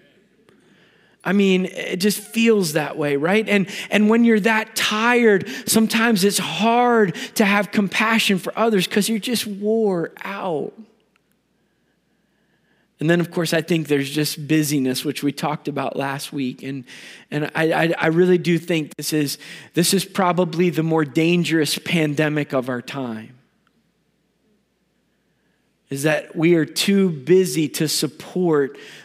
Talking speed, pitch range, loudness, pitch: 145 wpm, 150-210 Hz, -19 LUFS, 175 Hz